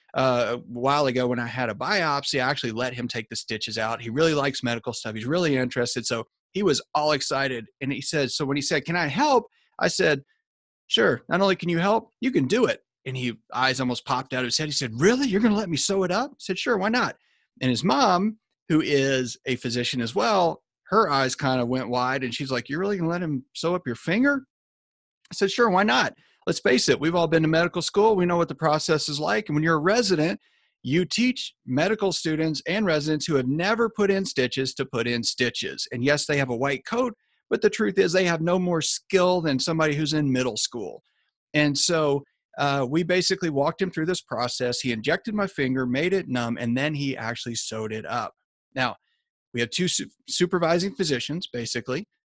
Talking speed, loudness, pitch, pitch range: 230 wpm, -24 LUFS, 150 Hz, 125-185 Hz